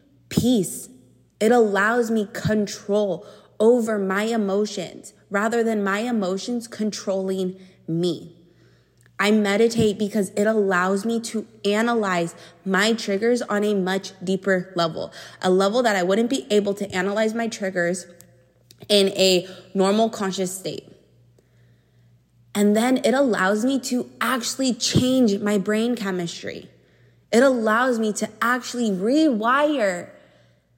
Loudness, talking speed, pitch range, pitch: -22 LUFS, 120 wpm, 185-225 Hz, 205 Hz